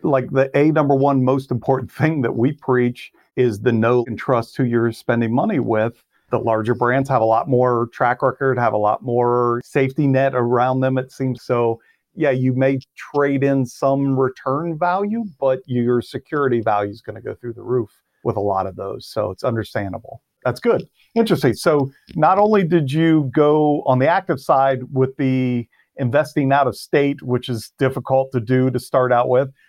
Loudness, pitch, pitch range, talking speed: -19 LUFS, 130 Hz, 120-140 Hz, 195 wpm